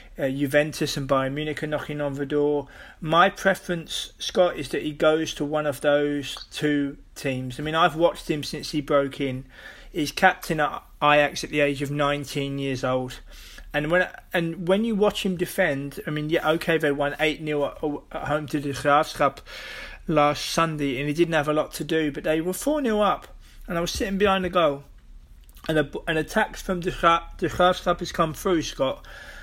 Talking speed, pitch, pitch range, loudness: 200 wpm, 150 Hz, 145-170 Hz, -24 LUFS